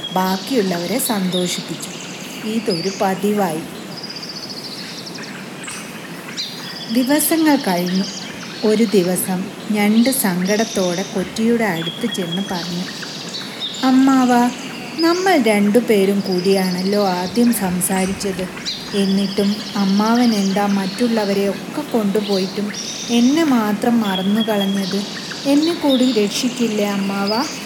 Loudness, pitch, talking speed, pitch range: -18 LUFS, 205 Hz, 75 wpm, 195-235 Hz